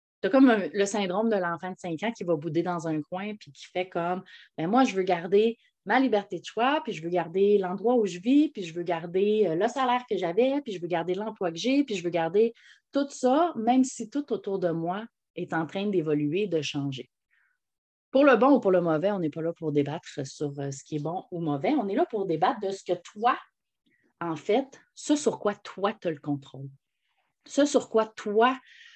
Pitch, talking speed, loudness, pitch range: 195 Hz, 230 wpm, -27 LUFS, 170-240 Hz